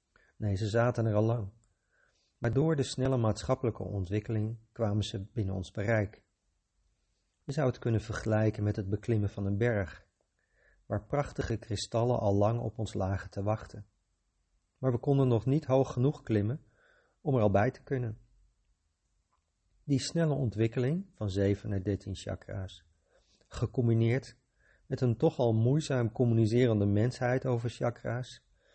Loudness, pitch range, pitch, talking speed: -31 LUFS, 100-125 Hz, 115 Hz, 145 wpm